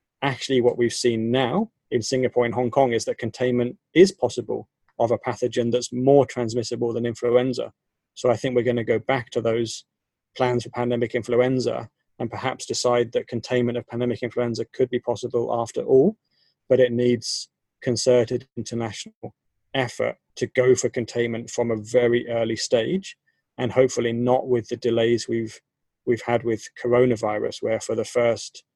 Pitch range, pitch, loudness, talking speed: 120-125 Hz, 120 Hz, -23 LUFS, 165 wpm